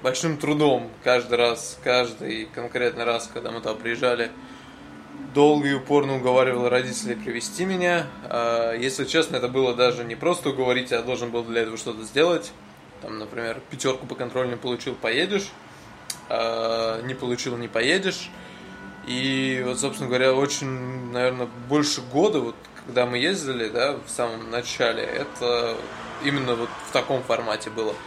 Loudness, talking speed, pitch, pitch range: -24 LUFS, 145 wpm, 125 Hz, 120-135 Hz